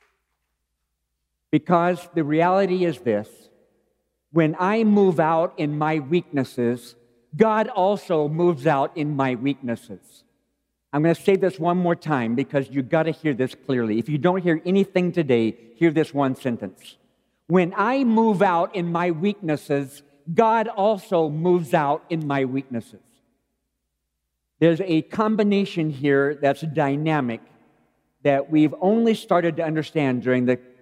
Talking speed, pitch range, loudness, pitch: 140 wpm, 130-180 Hz, -22 LUFS, 155 Hz